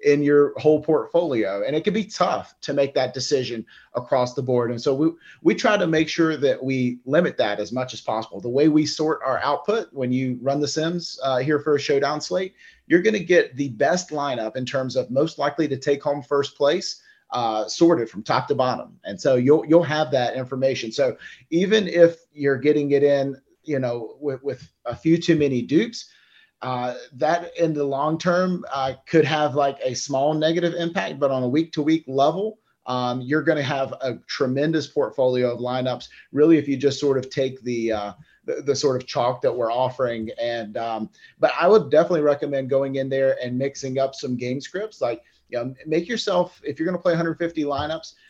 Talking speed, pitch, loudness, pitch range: 210 wpm, 145 Hz, -22 LUFS, 130-160 Hz